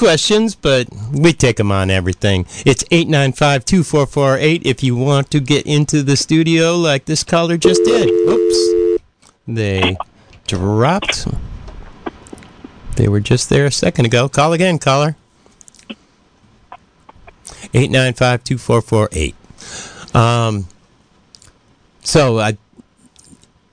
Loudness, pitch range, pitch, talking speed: -14 LUFS, 105-150 Hz, 125 Hz, 100 wpm